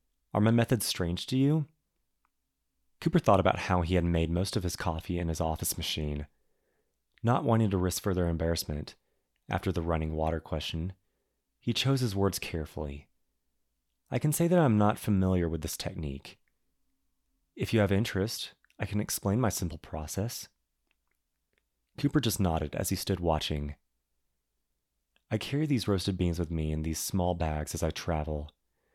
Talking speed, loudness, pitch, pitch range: 165 wpm, -30 LUFS, 90 Hz, 75-105 Hz